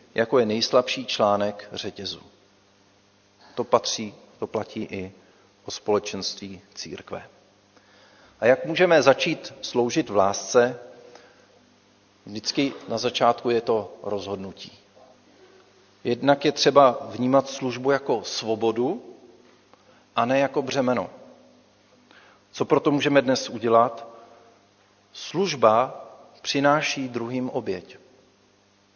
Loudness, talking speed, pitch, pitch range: -23 LUFS, 95 wpm, 115 Hz, 100-135 Hz